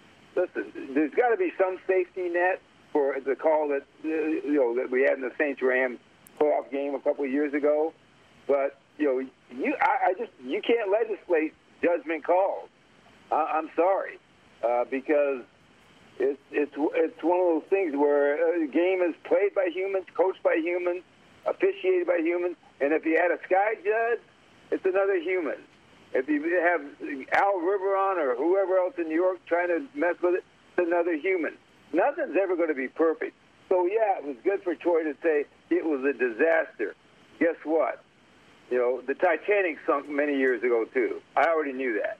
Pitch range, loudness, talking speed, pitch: 145-195 Hz, -27 LUFS, 180 wpm, 175 Hz